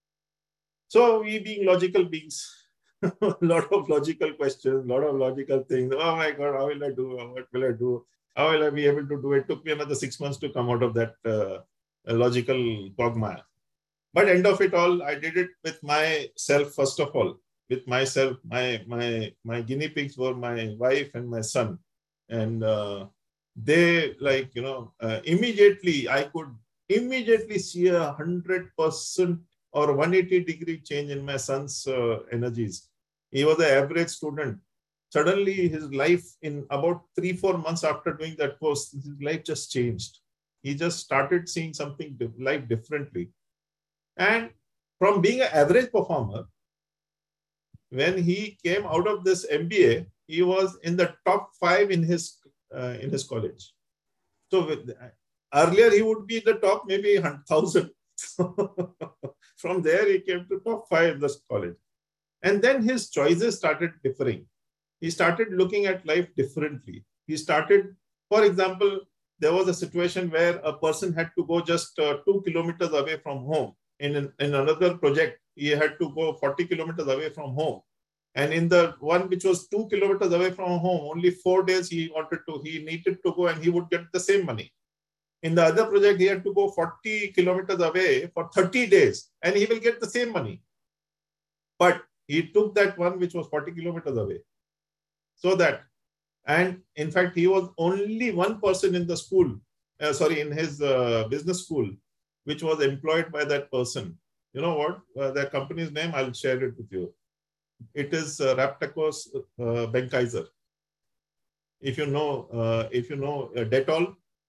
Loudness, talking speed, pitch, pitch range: -25 LUFS, 175 wpm, 155 Hz, 140-185 Hz